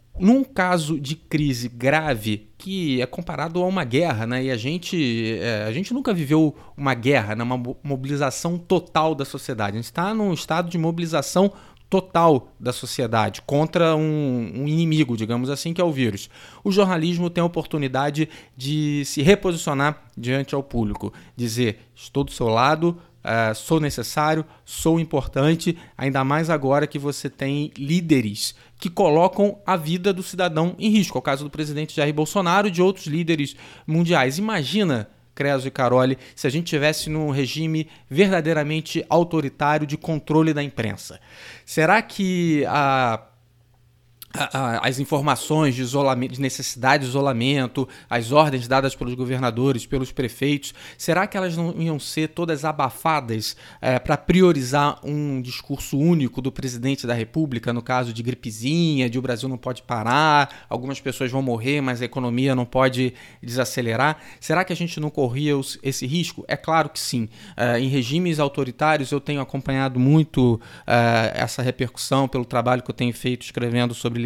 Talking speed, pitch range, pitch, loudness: 160 wpm, 125-160 Hz, 140 Hz, -22 LUFS